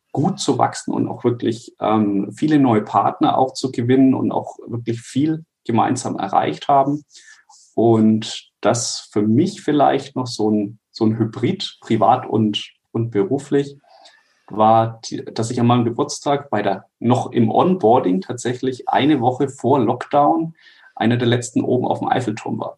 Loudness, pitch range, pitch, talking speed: -19 LUFS, 110-140 Hz, 120 Hz, 155 wpm